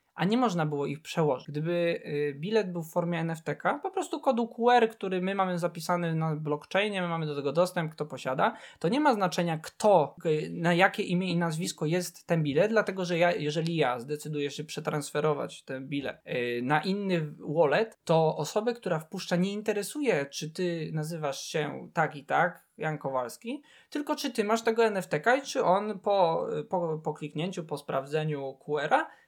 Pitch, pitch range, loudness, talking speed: 170 Hz, 150-195 Hz, -29 LUFS, 180 wpm